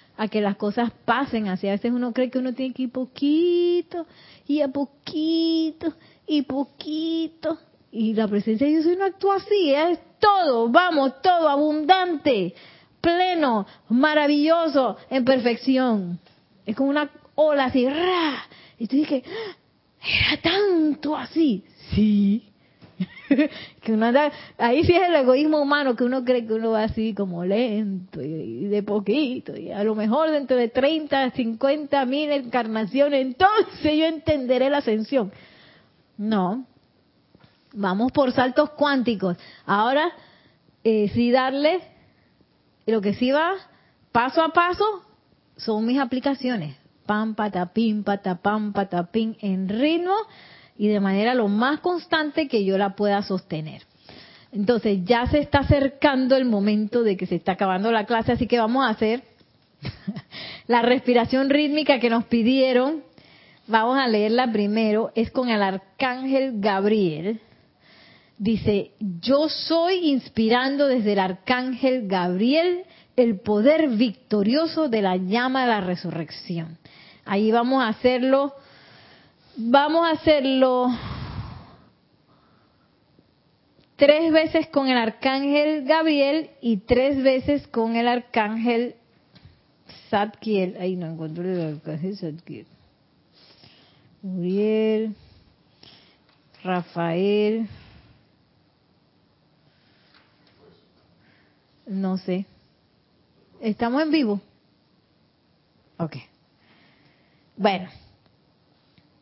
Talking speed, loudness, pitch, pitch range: 115 wpm, -22 LUFS, 245 Hz, 210-290 Hz